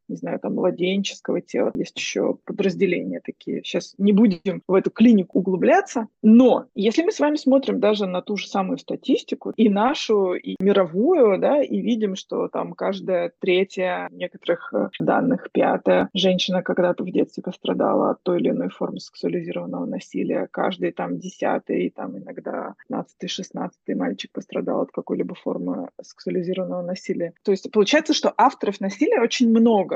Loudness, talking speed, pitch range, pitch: -22 LUFS, 150 wpm, 185-240 Hz, 200 Hz